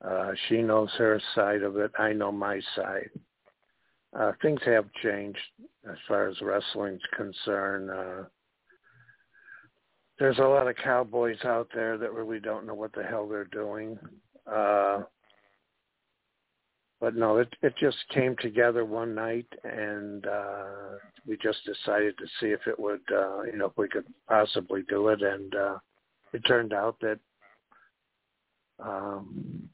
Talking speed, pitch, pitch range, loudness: 150 wpm, 105 Hz, 100-115 Hz, -29 LUFS